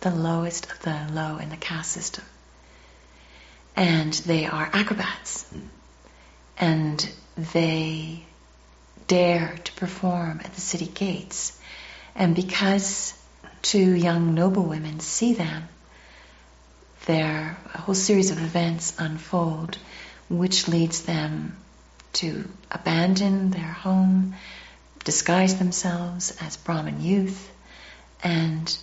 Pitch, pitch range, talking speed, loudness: 165 Hz, 155-185 Hz, 100 wpm, -25 LUFS